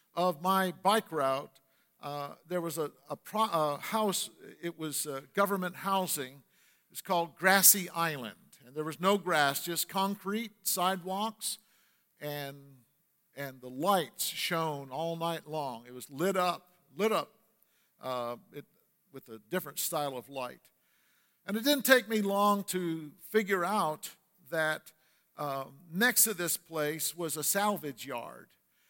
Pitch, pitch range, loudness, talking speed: 170 Hz, 145-195 Hz, -31 LUFS, 145 wpm